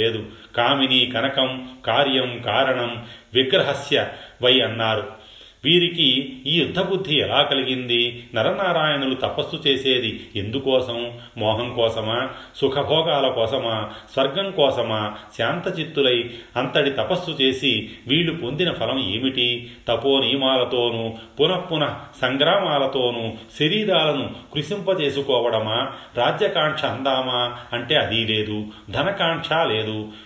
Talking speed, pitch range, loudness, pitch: 90 wpm, 115-140 Hz, -21 LUFS, 130 Hz